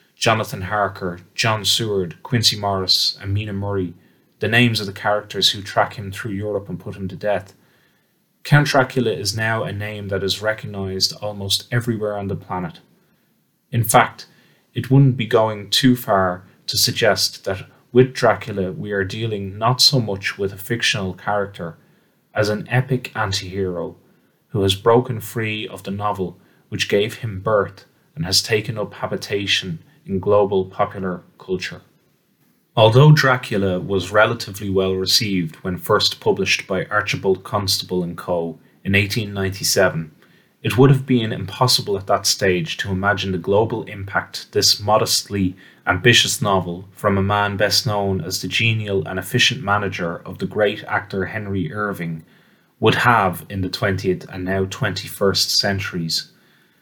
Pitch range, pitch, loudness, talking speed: 95-115 Hz, 100 Hz, -19 LUFS, 150 wpm